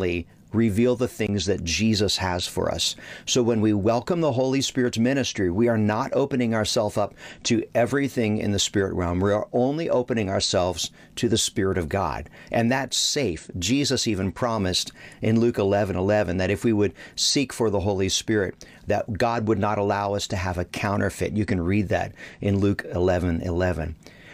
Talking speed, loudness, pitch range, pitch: 185 wpm, -24 LUFS, 95-115 Hz, 105 Hz